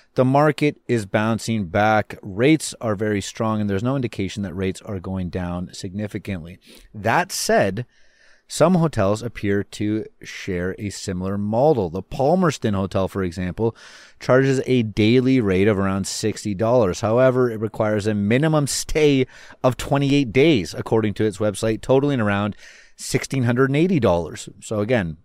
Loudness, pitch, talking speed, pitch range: -21 LUFS, 110 Hz, 140 wpm, 100-130 Hz